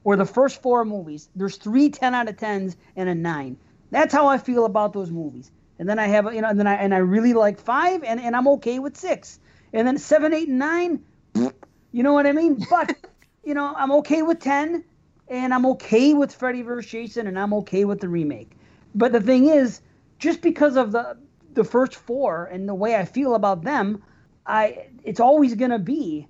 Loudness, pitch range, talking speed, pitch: -21 LUFS, 205-280 Hz, 220 wpm, 240 Hz